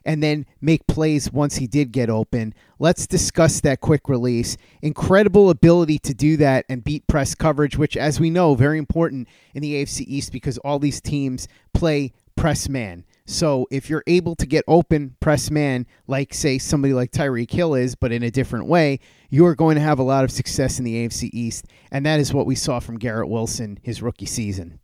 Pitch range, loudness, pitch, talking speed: 120-150 Hz, -20 LUFS, 140 Hz, 210 wpm